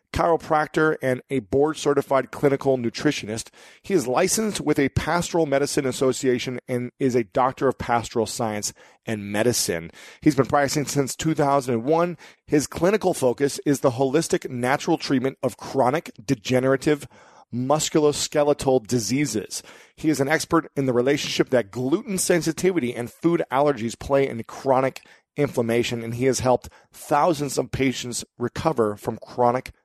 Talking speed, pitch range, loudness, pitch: 140 wpm, 125-150 Hz, -23 LUFS, 135 Hz